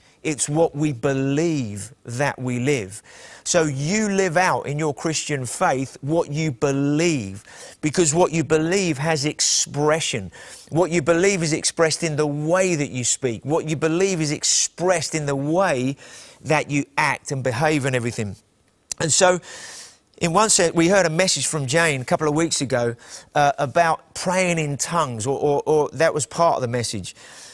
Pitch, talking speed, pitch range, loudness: 150 Hz, 175 wpm, 135-170 Hz, -21 LUFS